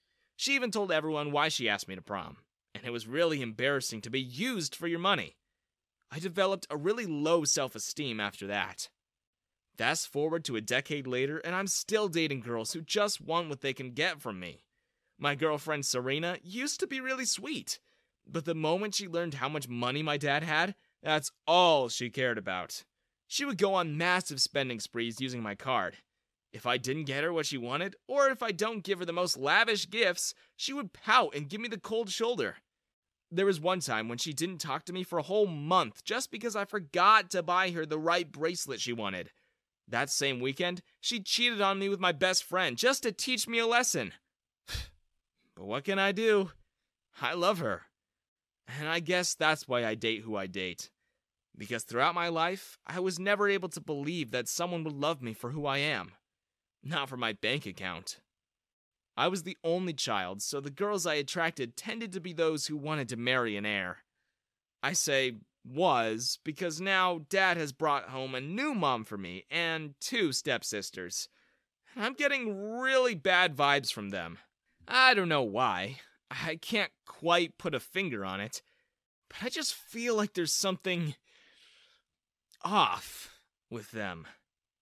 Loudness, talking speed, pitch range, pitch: -31 LUFS, 185 wpm, 130-195 Hz, 165 Hz